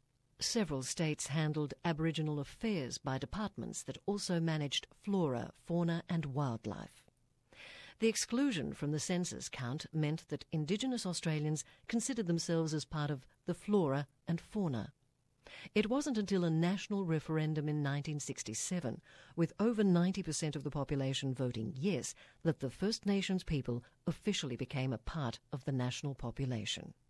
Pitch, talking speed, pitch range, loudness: 155 Hz, 135 wpm, 135-180 Hz, -37 LUFS